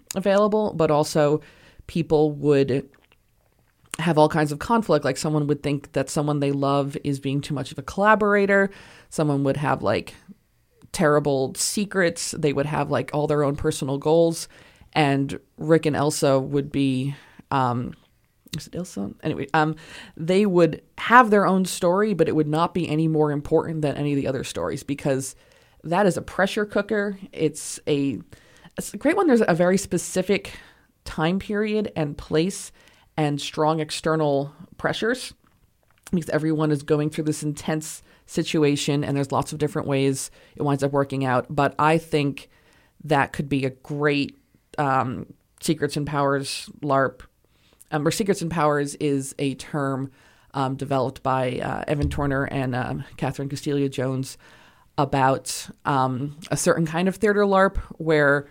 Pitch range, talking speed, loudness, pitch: 140-165 Hz, 160 wpm, -23 LUFS, 150 Hz